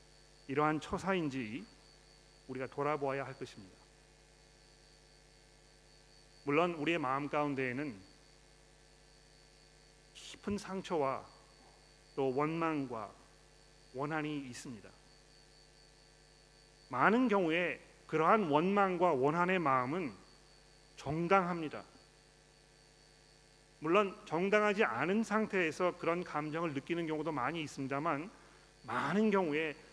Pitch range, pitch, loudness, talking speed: 140-180 Hz, 155 Hz, -35 LUFS, 210 characters per minute